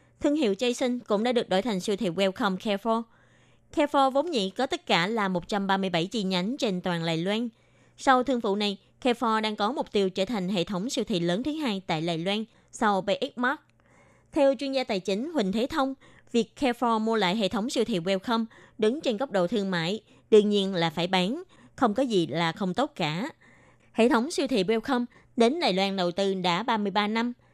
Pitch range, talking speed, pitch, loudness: 195-250 Hz, 215 wpm, 215 Hz, -27 LUFS